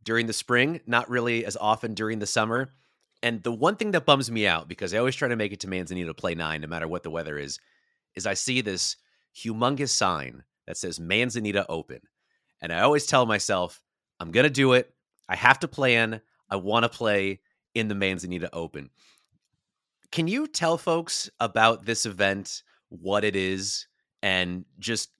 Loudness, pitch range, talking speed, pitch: -25 LUFS, 95-125 Hz, 190 wpm, 110 Hz